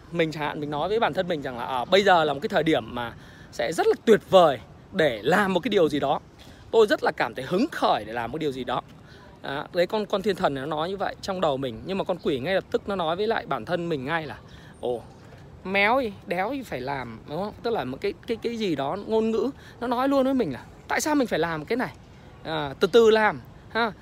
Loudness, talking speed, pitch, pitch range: -25 LUFS, 285 wpm, 190 Hz, 150-230 Hz